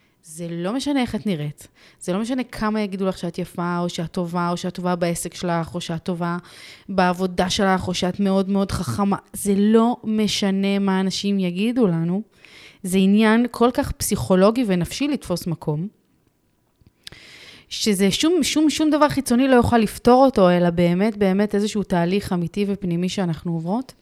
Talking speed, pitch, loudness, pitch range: 165 wpm, 195 Hz, -21 LUFS, 175-215 Hz